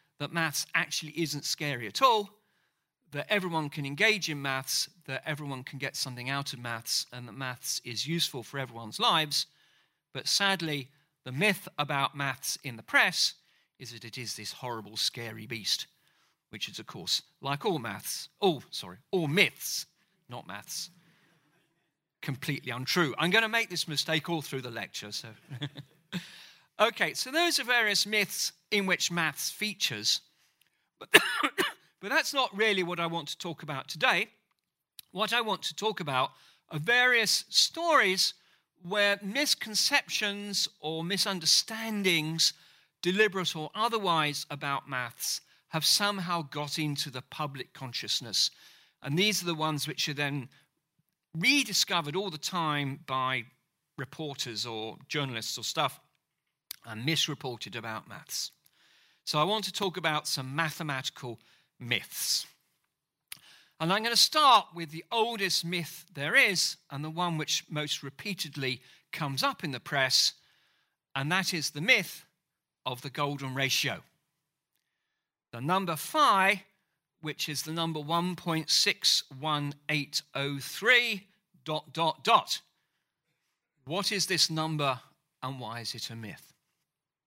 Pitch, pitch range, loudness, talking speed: 155 Hz, 140-185 Hz, -29 LUFS, 140 wpm